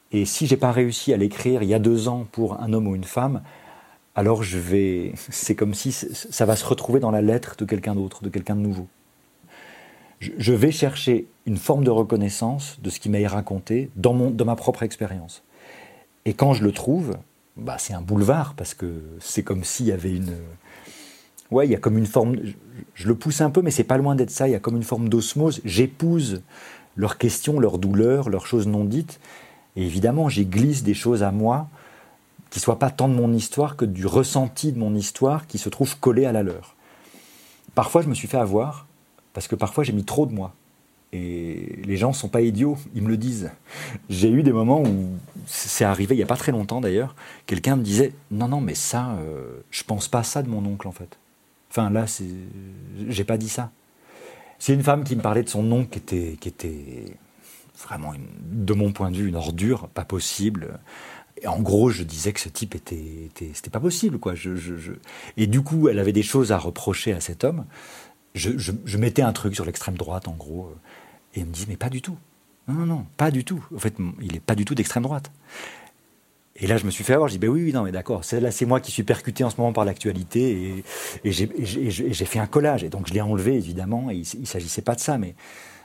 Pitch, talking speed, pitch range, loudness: 110 Hz, 240 wpm, 95-125 Hz, -23 LUFS